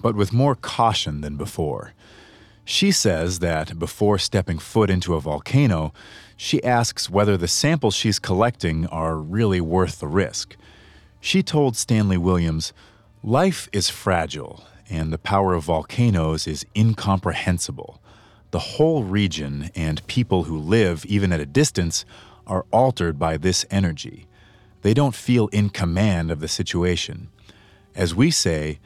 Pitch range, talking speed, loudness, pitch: 85-110 Hz, 140 wpm, -21 LUFS, 100 Hz